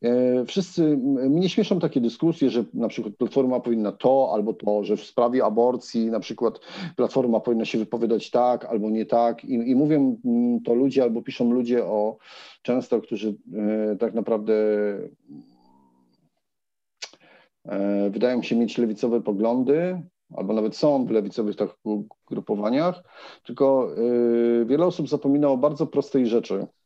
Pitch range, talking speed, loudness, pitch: 110-140 Hz, 140 wpm, -23 LUFS, 120 Hz